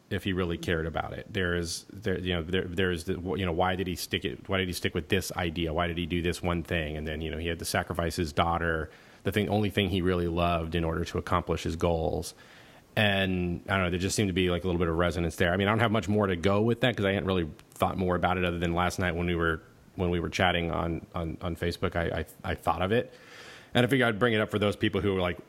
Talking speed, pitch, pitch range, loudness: 300 wpm, 90 Hz, 85-95 Hz, -29 LUFS